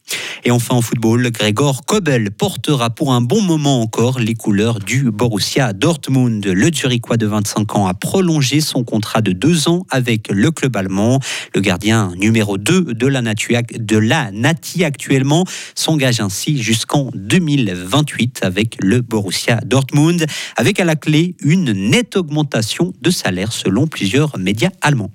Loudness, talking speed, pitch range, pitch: -15 LUFS, 155 wpm, 110-150 Hz, 125 Hz